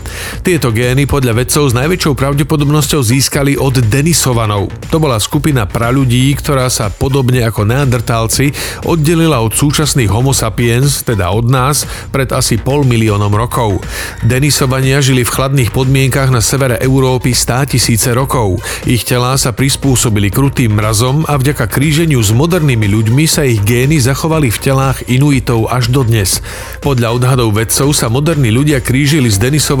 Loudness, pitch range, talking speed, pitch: -11 LUFS, 115-140 Hz, 150 wpm, 130 Hz